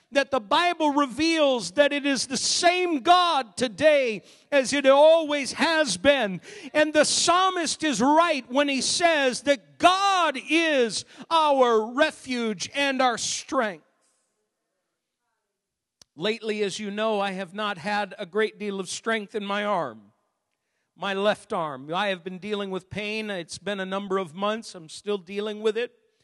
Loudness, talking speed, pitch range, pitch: -24 LUFS, 155 wpm, 205-295 Hz, 235 Hz